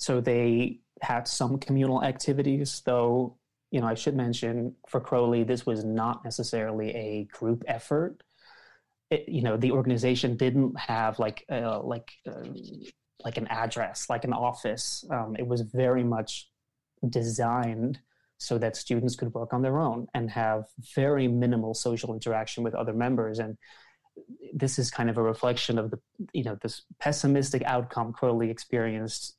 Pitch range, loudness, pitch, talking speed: 115-130 Hz, -29 LUFS, 120 Hz, 155 wpm